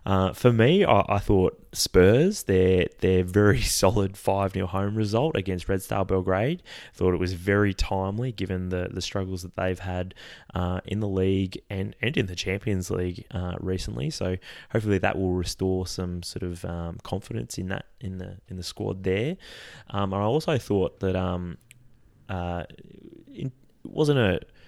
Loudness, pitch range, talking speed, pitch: -26 LUFS, 90-105 Hz, 175 wpm, 95 Hz